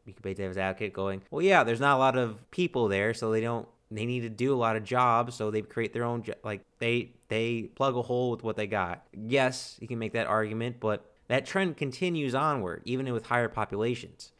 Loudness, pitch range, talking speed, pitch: -29 LUFS, 110-125 Hz, 240 wpm, 115 Hz